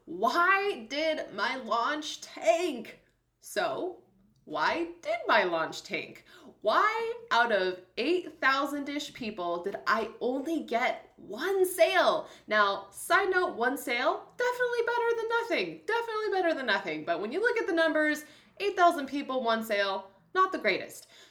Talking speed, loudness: 140 wpm, -29 LUFS